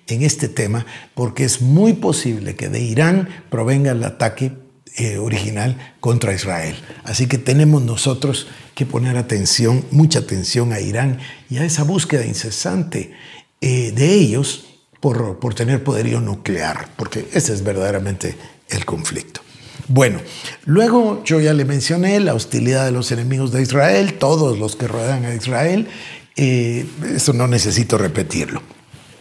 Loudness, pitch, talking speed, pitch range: -17 LUFS, 130 Hz, 145 wpm, 120-150 Hz